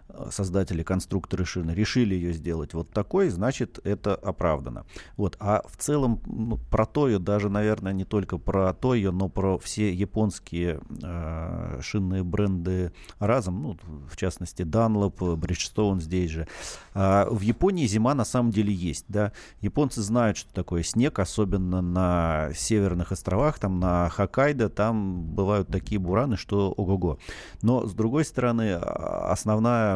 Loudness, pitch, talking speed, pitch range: -26 LUFS, 100 Hz, 145 wpm, 90-110 Hz